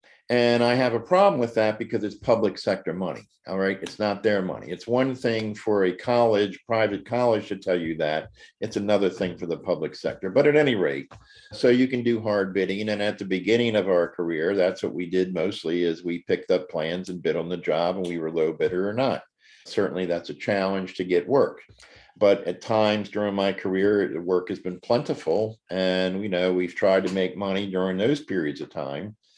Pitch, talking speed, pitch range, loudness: 100 Hz, 220 wpm, 90-115 Hz, -25 LUFS